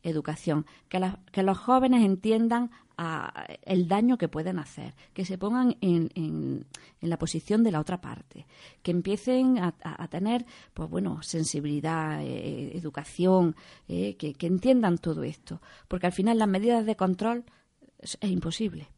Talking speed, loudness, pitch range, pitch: 165 wpm, -28 LUFS, 160-220 Hz, 185 Hz